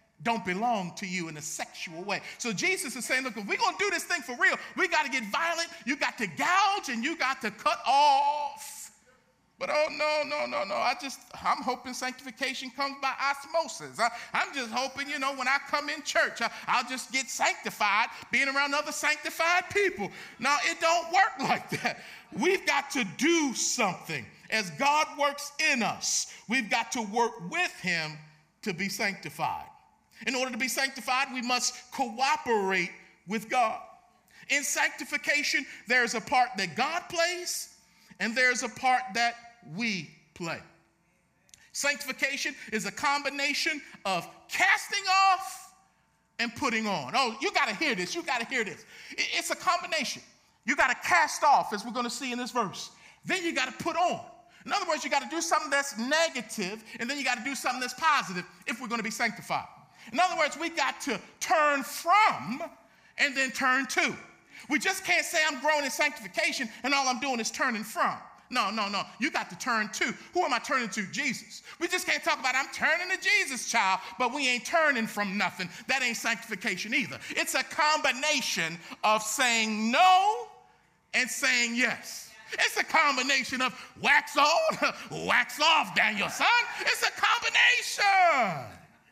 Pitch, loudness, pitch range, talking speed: 275 Hz, -28 LUFS, 235-320 Hz, 185 wpm